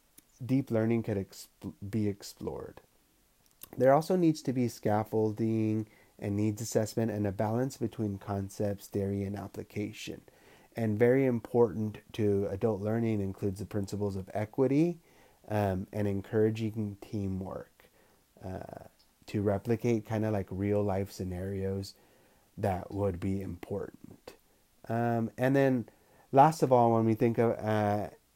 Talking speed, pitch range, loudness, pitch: 130 wpm, 100-115 Hz, -31 LUFS, 110 Hz